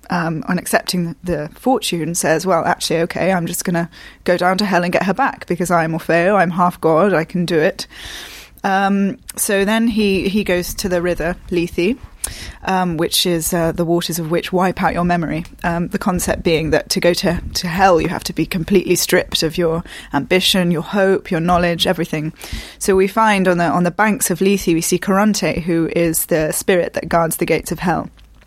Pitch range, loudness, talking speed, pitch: 170-190 Hz, -17 LUFS, 210 wpm, 175 Hz